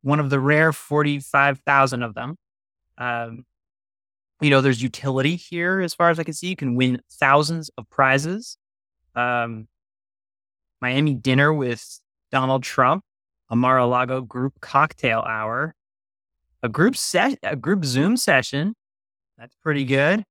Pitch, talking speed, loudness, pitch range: 135 Hz, 140 wpm, -21 LUFS, 120-150 Hz